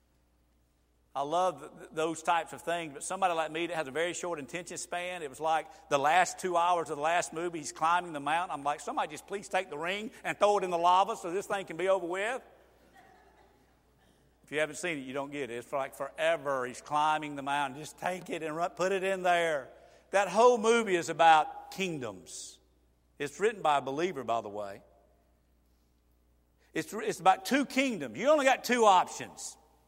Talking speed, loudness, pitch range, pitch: 200 wpm, -30 LUFS, 140-185 Hz, 165 Hz